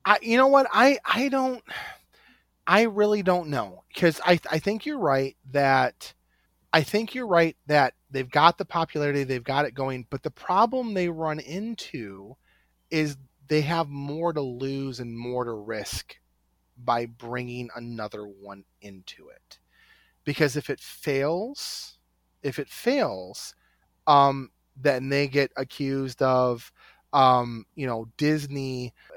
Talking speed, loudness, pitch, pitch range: 145 wpm, -25 LUFS, 140 Hz, 125-170 Hz